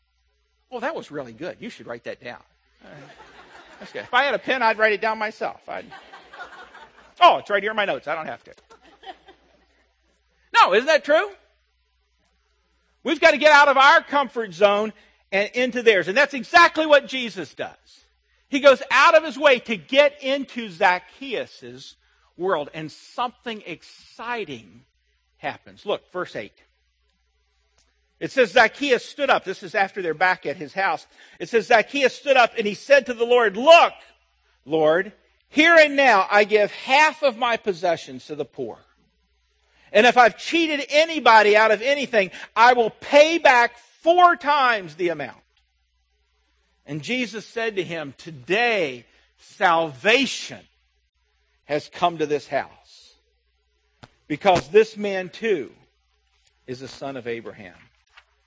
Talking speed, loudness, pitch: 155 wpm, -19 LUFS, 210 Hz